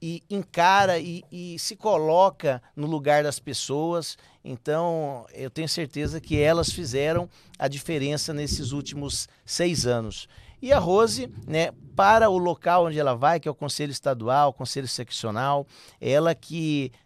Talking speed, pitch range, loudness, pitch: 150 wpm, 135-170 Hz, -24 LUFS, 150 Hz